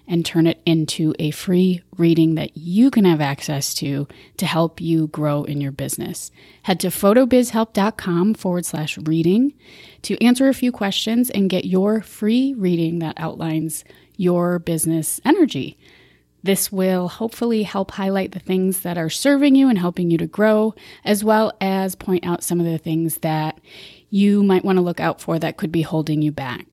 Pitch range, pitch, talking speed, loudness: 160-205 Hz, 180 Hz, 180 wpm, -19 LUFS